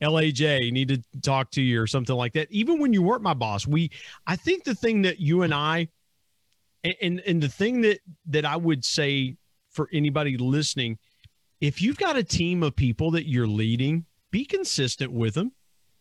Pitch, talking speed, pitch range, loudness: 150 Hz, 190 wpm, 130-175 Hz, -25 LUFS